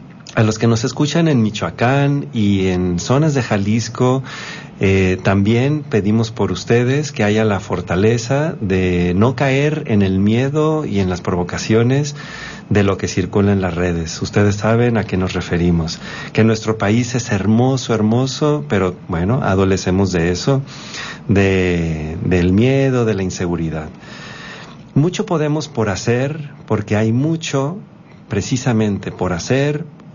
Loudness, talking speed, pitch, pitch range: -17 LUFS, 140 wpm, 110 Hz, 95-135 Hz